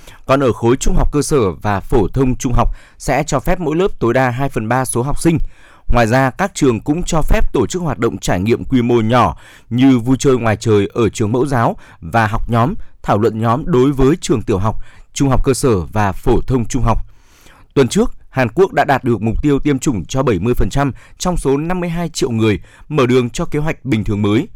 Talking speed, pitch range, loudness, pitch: 235 wpm, 110-145 Hz, -16 LUFS, 125 Hz